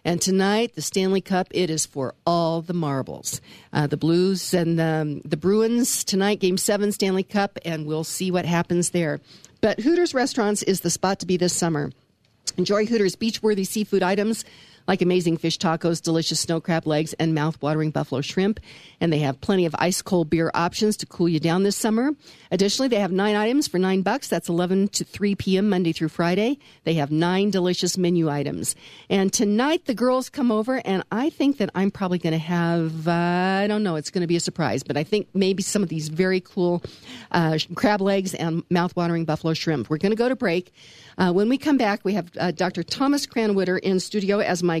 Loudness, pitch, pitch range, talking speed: -23 LUFS, 180 Hz, 165-205 Hz, 210 wpm